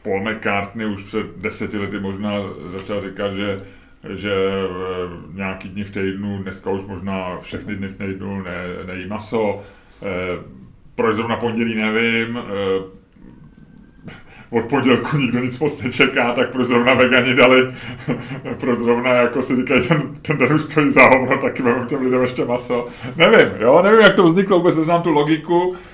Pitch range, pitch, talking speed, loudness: 95-130 Hz, 115 Hz, 155 wpm, -18 LUFS